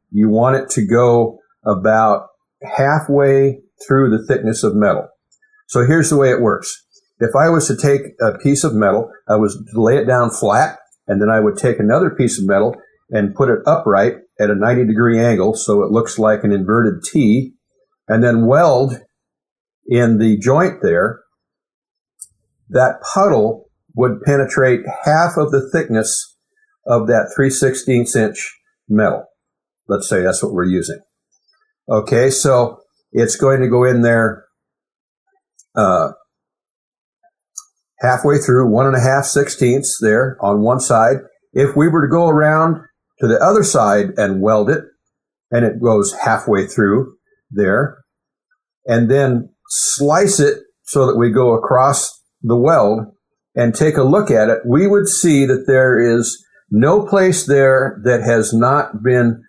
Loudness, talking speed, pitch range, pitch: -14 LUFS, 155 wpm, 115-155 Hz, 130 Hz